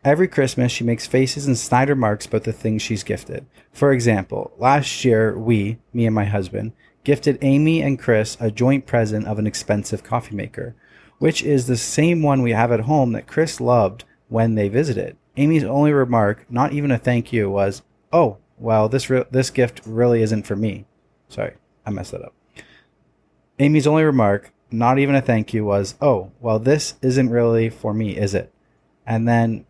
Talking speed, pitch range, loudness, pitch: 190 wpm, 110-135 Hz, -19 LUFS, 120 Hz